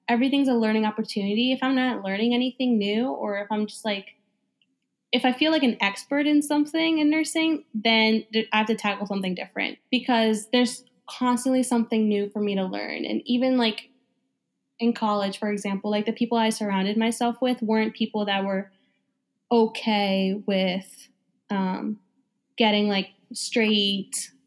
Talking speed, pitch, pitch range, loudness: 160 wpm, 225 Hz, 205-250 Hz, -24 LUFS